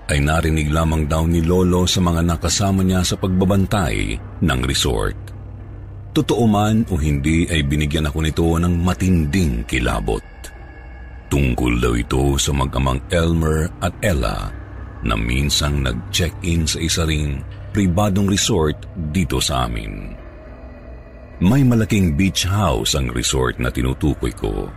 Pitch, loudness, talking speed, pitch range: 85 Hz, -19 LUFS, 130 wpm, 70-95 Hz